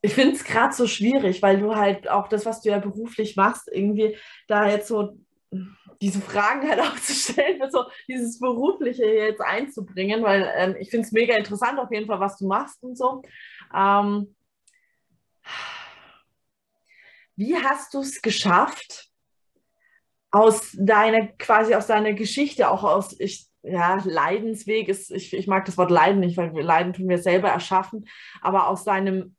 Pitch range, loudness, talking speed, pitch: 195-235 Hz, -22 LUFS, 165 wpm, 210 Hz